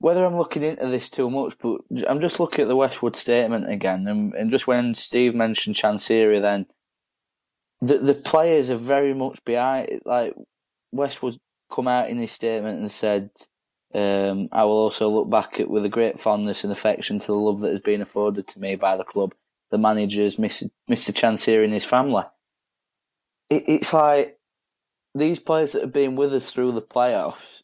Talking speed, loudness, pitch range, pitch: 190 wpm, -22 LUFS, 105-135 Hz, 120 Hz